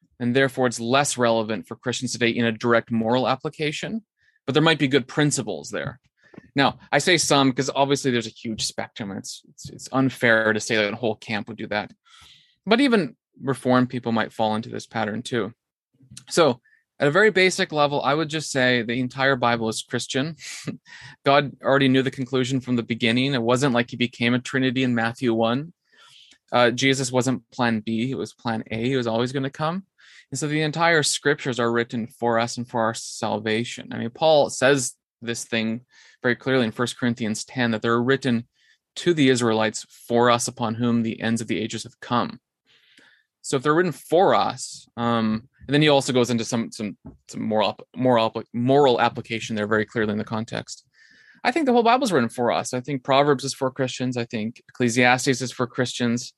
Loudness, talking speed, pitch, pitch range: -22 LUFS, 205 wpm, 125 Hz, 115-135 Hz